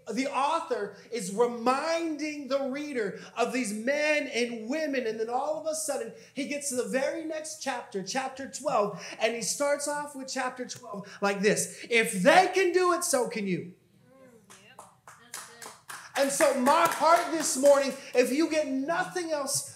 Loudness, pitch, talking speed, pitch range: -28 LUFS, 270 Hz, 165 wpm, 230-300 Hz